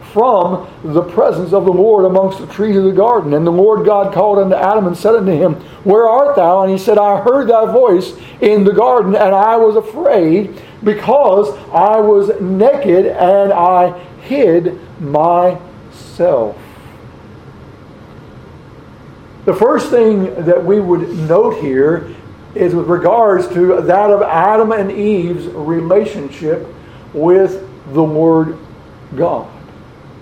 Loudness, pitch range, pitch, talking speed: -12 LUFS, 175-210 Hz, 190 Hz, 140 wpm